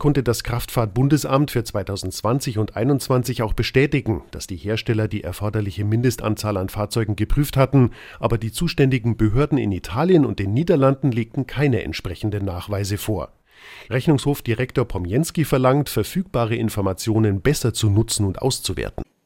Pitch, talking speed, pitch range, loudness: 115 Hz, 135 wpm, 105-135 Hz, -21 LUFS